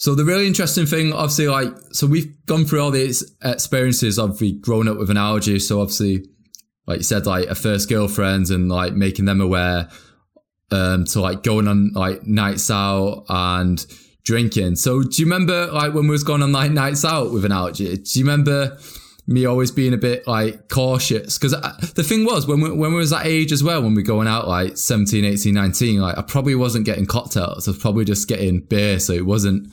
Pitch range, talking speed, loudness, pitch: 100-140 Hz, 215 wpm, -18 LUFS, 110 Hz